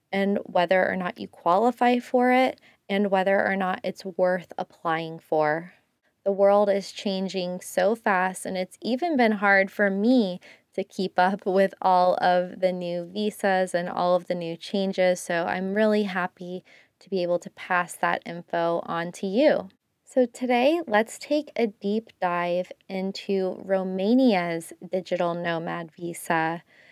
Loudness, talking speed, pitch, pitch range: -25 LUFS, 155 wpm, 190 Hz, 180-205 Hz